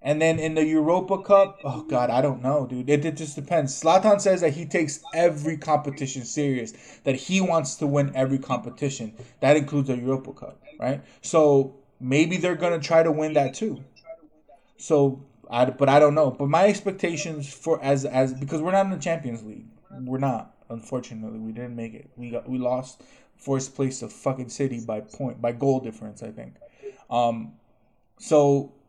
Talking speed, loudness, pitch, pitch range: 185 wpm, -24 LUFS, 140 Hz, 130-160 Hz